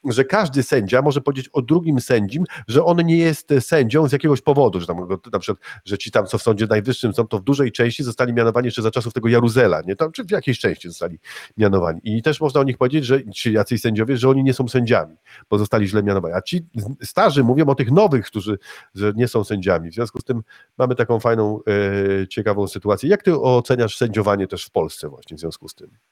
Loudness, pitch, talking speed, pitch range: -19 LUFS, 120 Hz, 230 wpm, 105-140 Hz